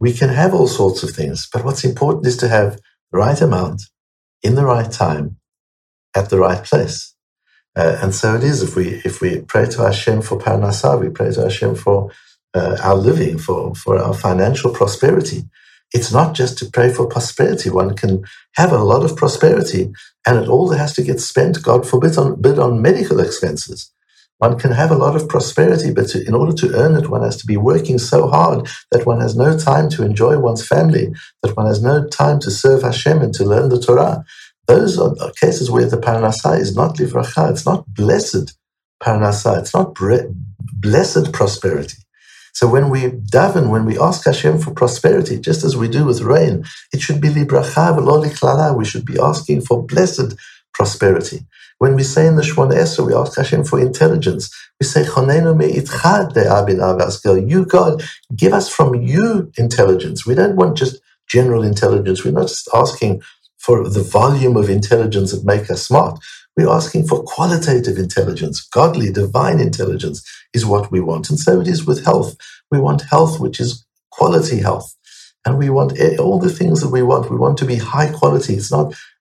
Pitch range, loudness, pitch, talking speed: 100-140 Hz, -15 LUFS, 120 Hz, 190 wpm